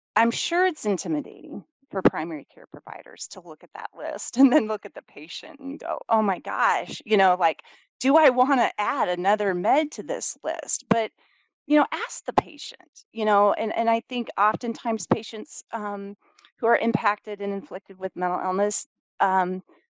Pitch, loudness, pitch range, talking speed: 215 Hz, -24 LUFS, 195-255 Hz, 180 wpm